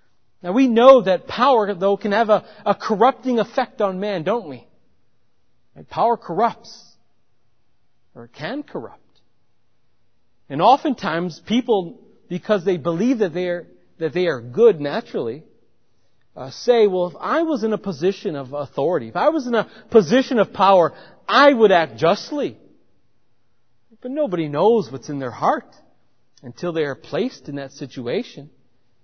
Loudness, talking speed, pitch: -19 LUFS, 150 wpm, 180 Hz